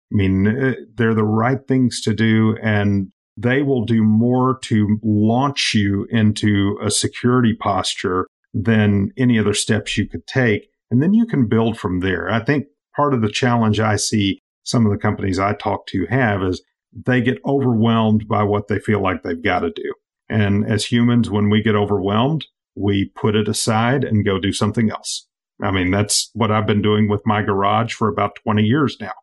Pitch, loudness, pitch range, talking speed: 110 Hz, -18 LUFS, 105-120 Hz, 195 wpm